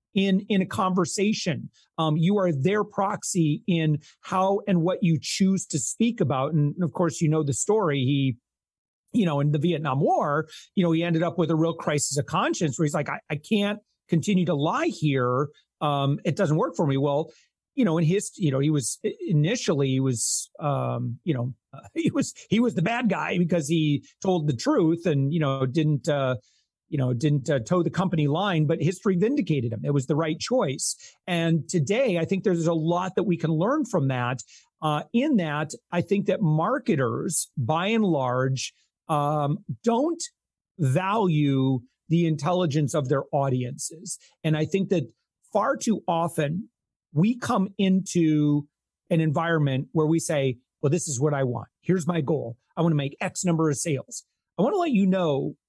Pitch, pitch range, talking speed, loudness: 165 Hz, 145-190 Hz, 190 wpm, -25 LUFS